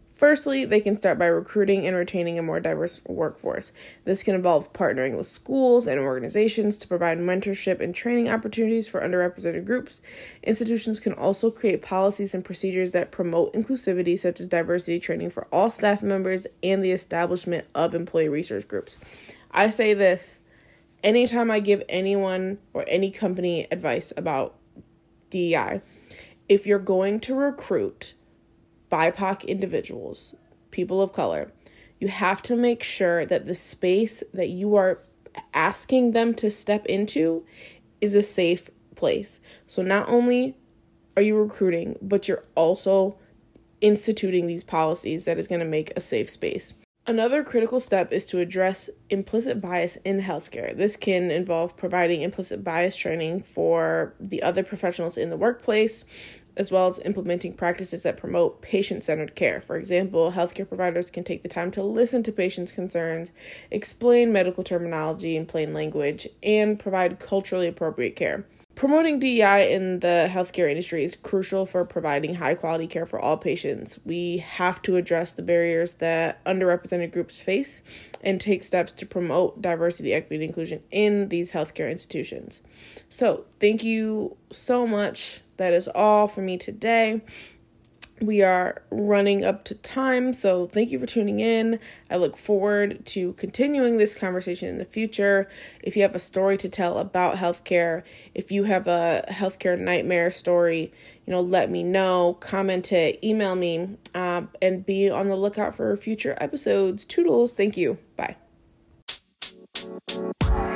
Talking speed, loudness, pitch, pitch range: 155 wpm, -24 LUFS, 190 Hz, 175-210 Hz